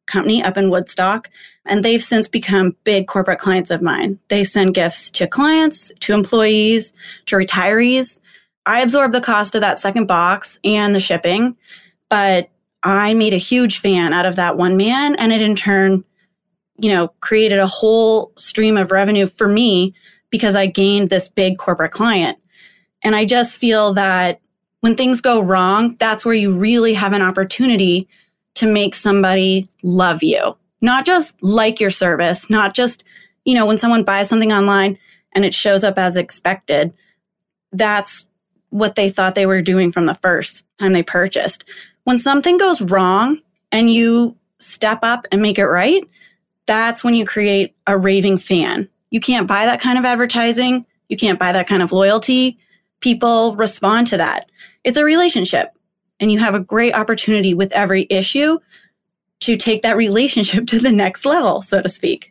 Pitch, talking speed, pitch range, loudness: 205 Hz, 170 wpm, 190-230 Hz, -15 LUFS